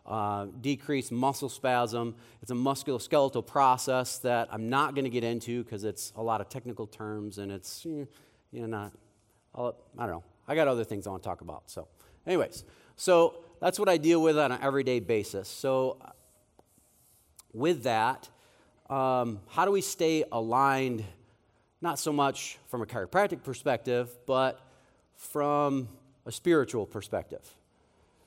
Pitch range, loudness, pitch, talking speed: 115-140 Hz, -30 LUFS, 125 Hz, 160 wpm